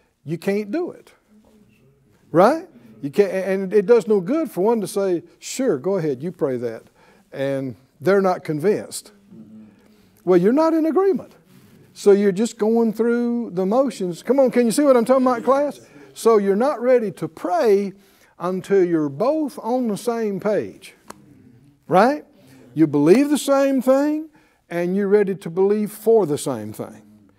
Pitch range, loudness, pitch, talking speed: 170-240 Hz, -20 LUFS, 205 Hz, 165 wpm